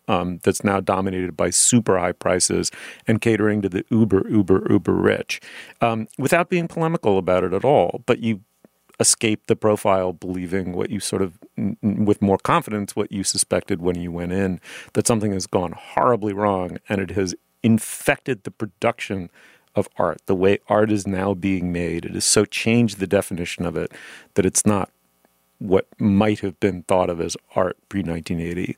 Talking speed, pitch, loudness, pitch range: 180 wpm, 100 Hz, -21 LUFS, 90-105 Hz